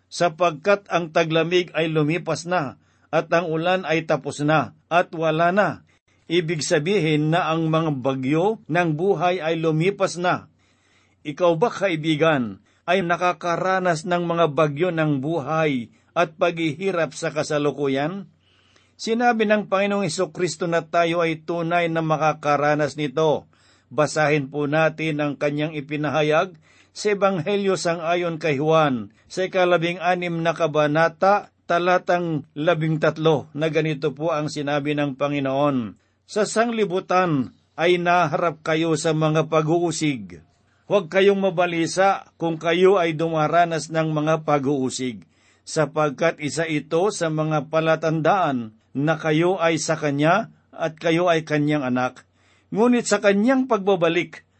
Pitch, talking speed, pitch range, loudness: 160 Hz, 130 wpm, 150-175 Hz, -21 LUFS